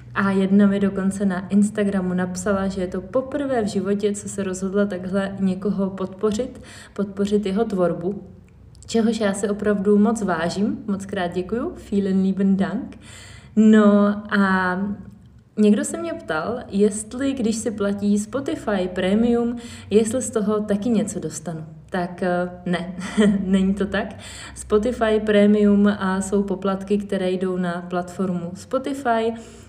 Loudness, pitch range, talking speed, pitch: -21 LUFS, 190-215 Hz, 135 wpm, 200 Hz